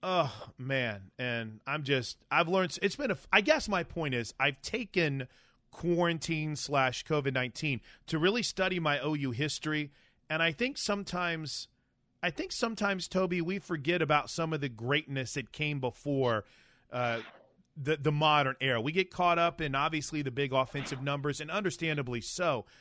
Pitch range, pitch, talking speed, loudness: 130-175 Hz, 150 Hz, 165 wpm, -31 LUFS